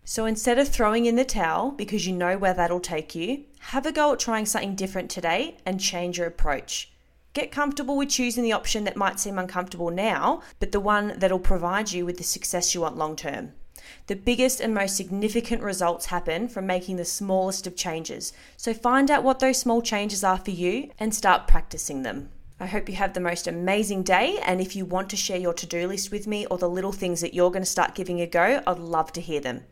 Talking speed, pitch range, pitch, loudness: 230 wpm, 180-220 Hz, 190 Hz, -25 LUFS